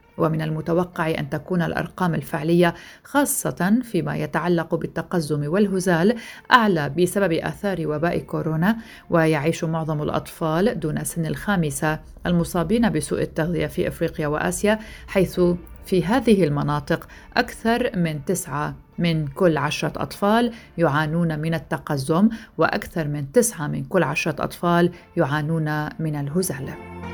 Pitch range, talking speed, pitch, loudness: 155-185 Hz, 115 wpm, 165 Hz, -22 LUFS